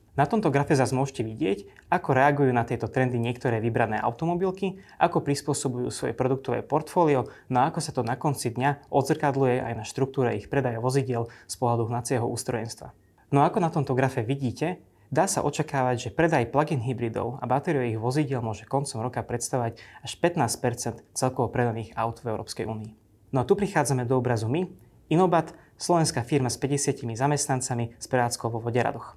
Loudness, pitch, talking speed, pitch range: -26 LUFS, 130 Hz, 170 wpm, 120-145 Hz